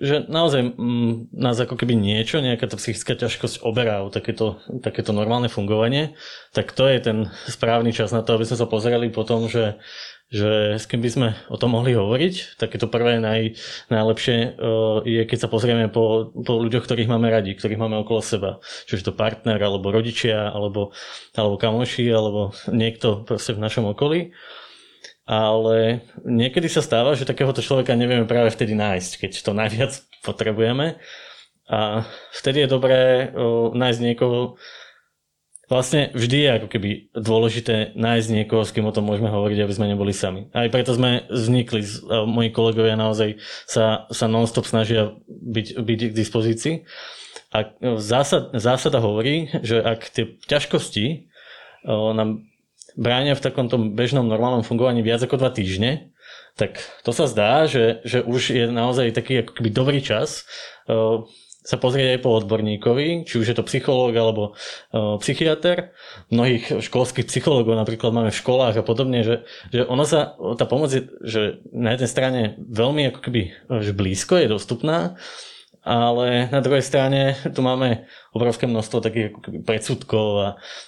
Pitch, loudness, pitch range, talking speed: 115 Hz, -21 LUFS, 110-125 Hz, 160 wpm